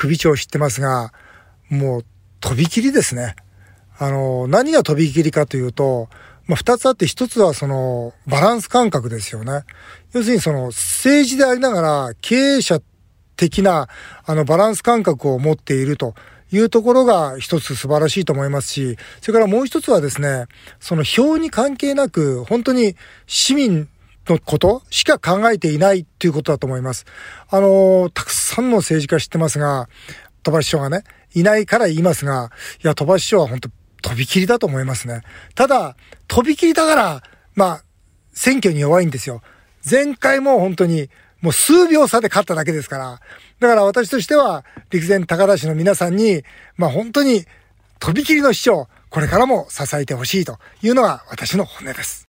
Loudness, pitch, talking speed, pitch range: -16 LUFS, 165 Hz, 340 characters per minute, 135-225 Hz